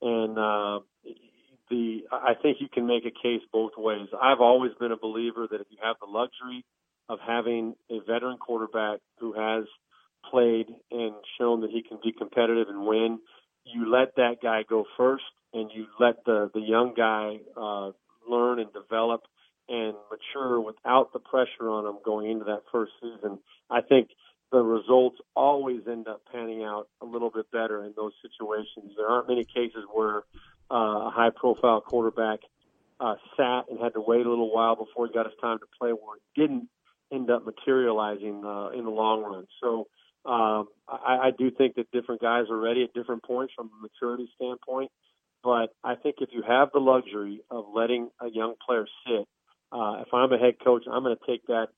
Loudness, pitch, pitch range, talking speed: -27 LUFS, 115 Hz, 110-125 Hz, 190 wpm